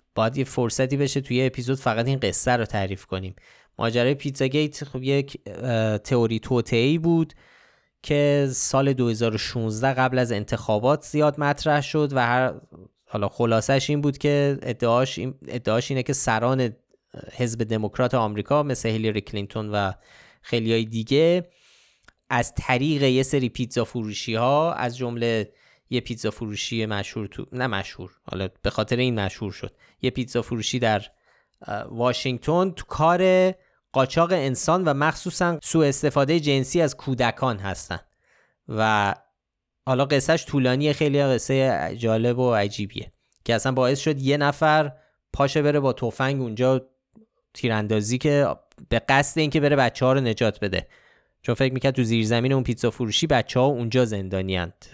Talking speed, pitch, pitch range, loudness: 145 wpm, 125 Hz, 115-140 Hz, -23 LUFS